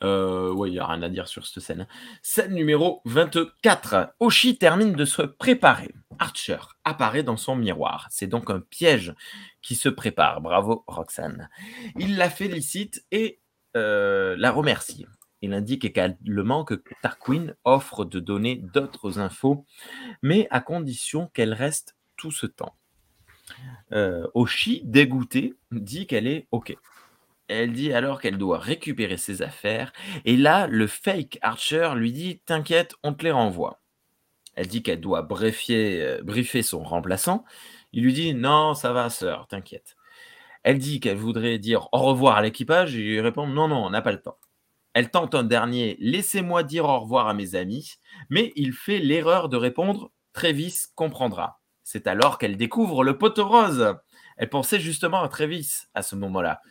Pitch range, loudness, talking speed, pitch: 115-175 Hz, -24 LUFS, 165 wpm, 140 Hz